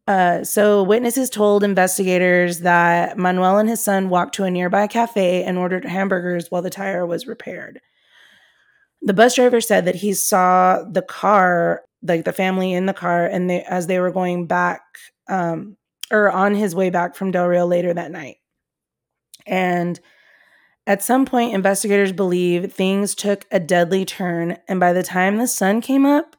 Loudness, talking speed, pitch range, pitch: -18 LUFS, 175 wpm, 180-205 Hz, 185 Hz